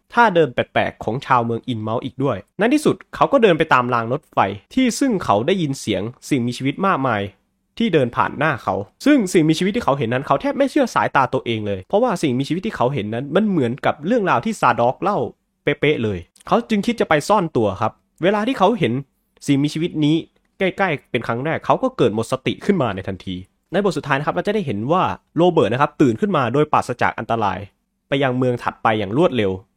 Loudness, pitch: -19 LUFS, 145 Hz